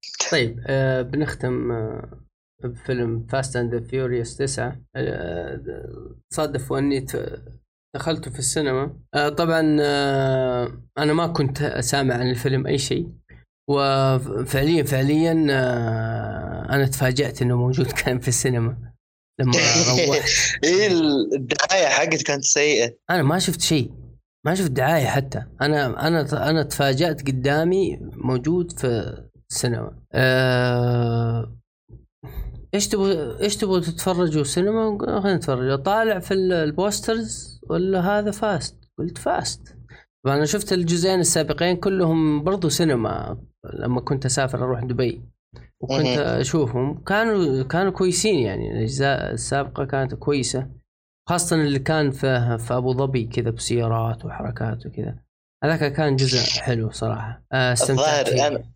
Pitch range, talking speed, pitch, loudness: 125-160 Hz, 115 wpm, 135 Hz, -21 LUFS